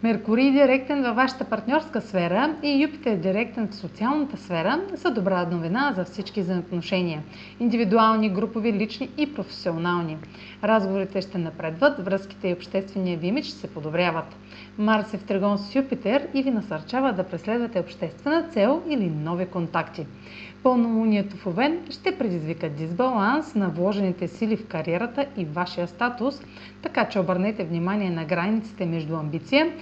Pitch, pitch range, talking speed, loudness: 205 Hz, 180-255 Hz, 145 wpm, -25 LUFS